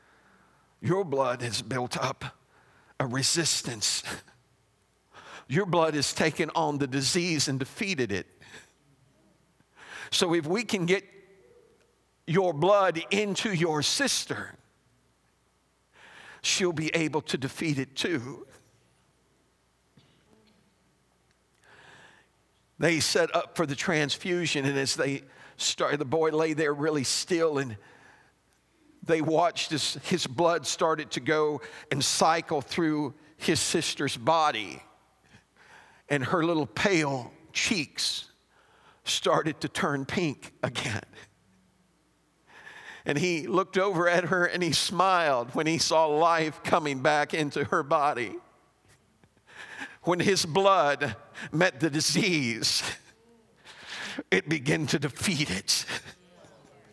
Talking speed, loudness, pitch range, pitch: 110 wpm, -27 LUFS, 140-175 Hz, 160 Hz